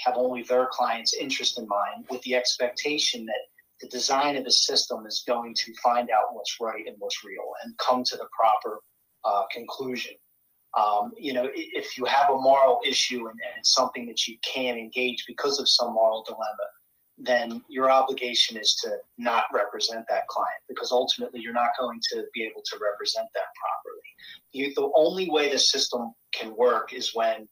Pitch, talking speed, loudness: 125 Hz, 190 wpm, -25 LUFS